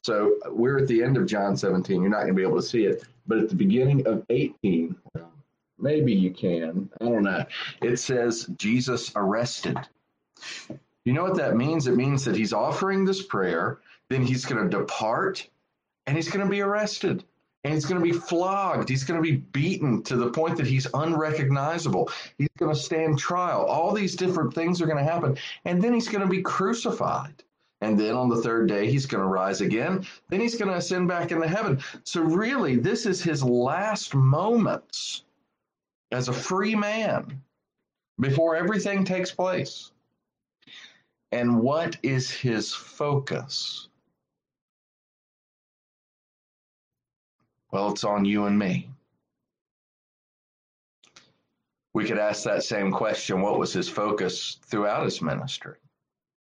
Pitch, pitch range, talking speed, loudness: 150 Hz, 125-185 Hz, 160 wpm, -25 LUFS